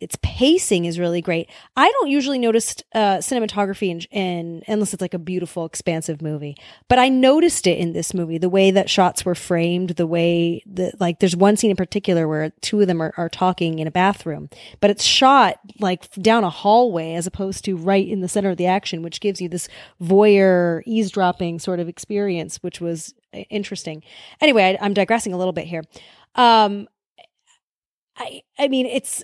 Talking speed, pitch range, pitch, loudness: 195 wpm, 170-210 Hz, 190 Hz, -19 LUFS